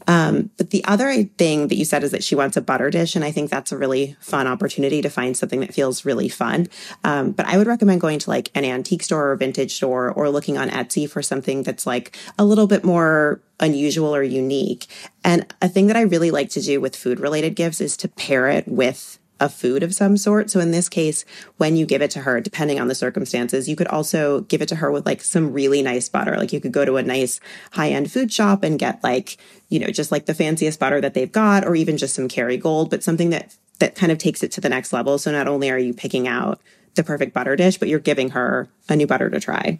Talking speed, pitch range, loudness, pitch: 255 wpm, 135-185 Hz, -20 LUFS, 155 Hz